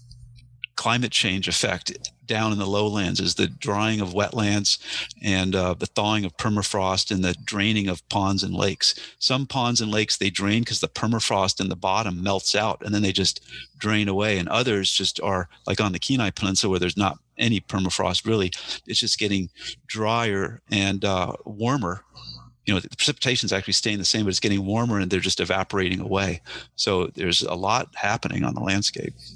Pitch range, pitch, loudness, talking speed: 95-110 Hz, 100 Hz, -23 LUFS, 190 wpm